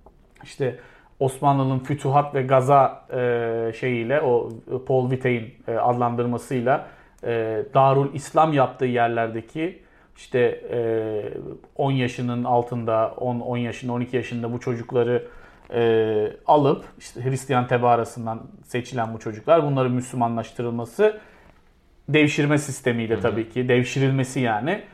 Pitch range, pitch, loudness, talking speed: 115-135 Hz, 125 Hz, -23 LUFS, 95 wpm